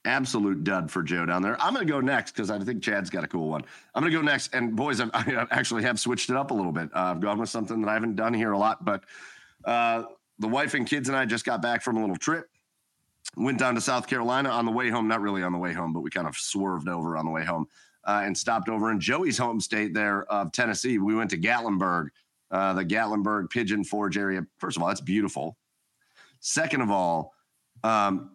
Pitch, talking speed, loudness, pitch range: 105 Hz, 250 wpm, -27 LUFS, 95-115 Hz